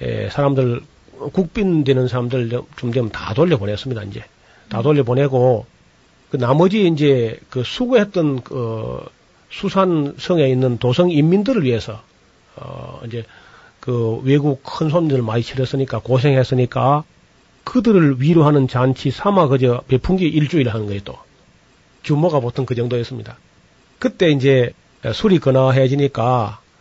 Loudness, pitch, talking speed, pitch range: -17 LUFS, 135 Hz, 280 characters per minute, 125-155 Hz